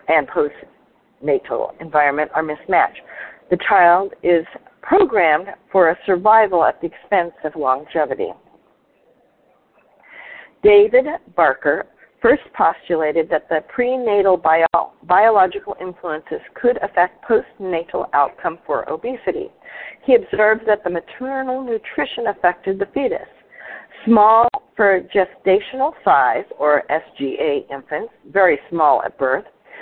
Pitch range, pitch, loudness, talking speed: 170-260 Hz, 200 Hz, -18 LUFS, 105 wpm